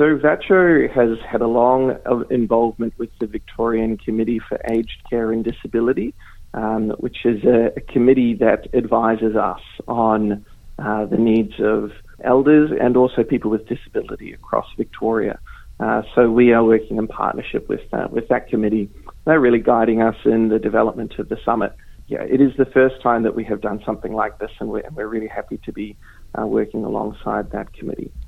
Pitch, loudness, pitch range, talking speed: 115 Hz, -19 LUFS, 110-120 Hz, 180 wpm